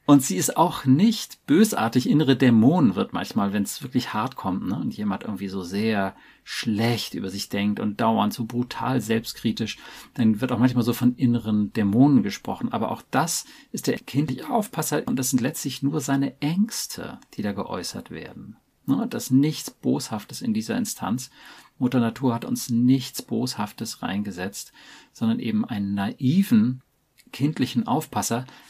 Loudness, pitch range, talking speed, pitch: -24 LUFS, 110-145 Hz, 165 wpm, 125 Hz